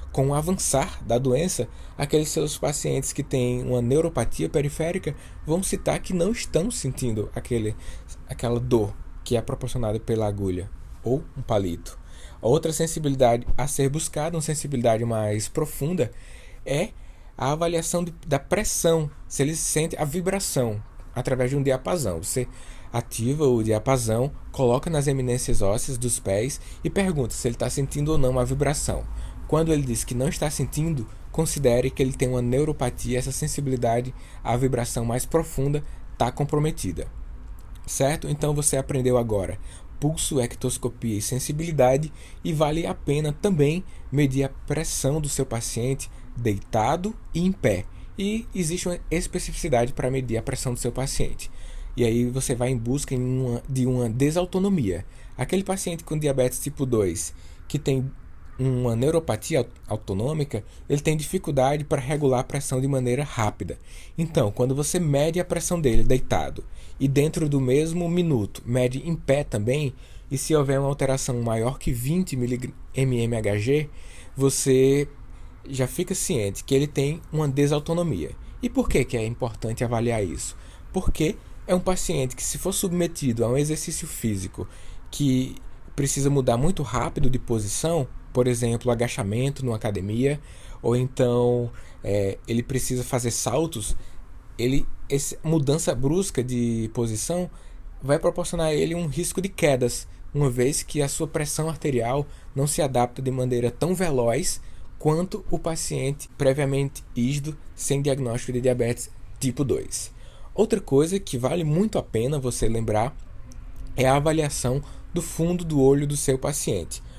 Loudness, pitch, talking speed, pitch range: -25 LUFS, 135 Hz, 150 wpm, 120-155 Hz